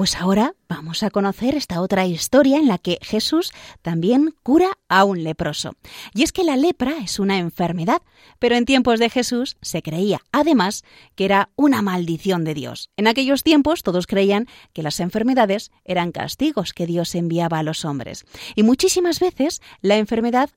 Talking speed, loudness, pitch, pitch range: 175 wpm, -19 LUFS, 210 Hz, 175-270 Hz